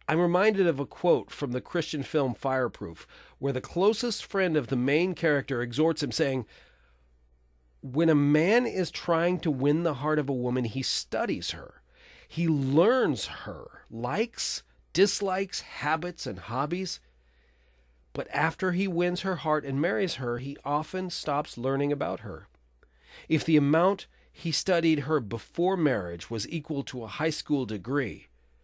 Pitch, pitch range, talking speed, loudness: 145 Hz, 125-170 Hz, 155 wpm, -28 LUFS